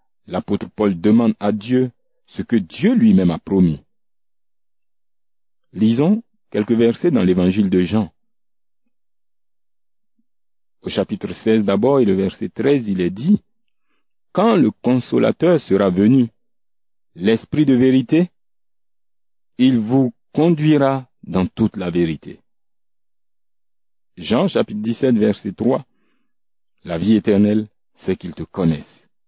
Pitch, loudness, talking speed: 120 Hz, -18 LUFS, 115 wpm